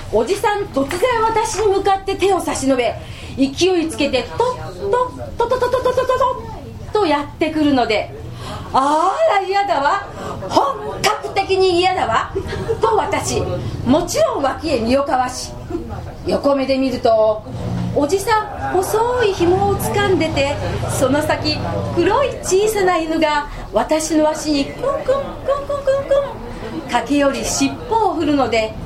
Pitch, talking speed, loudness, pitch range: 345 Hz, 255 characters per minute, -18 LUFS, 275-415 Hz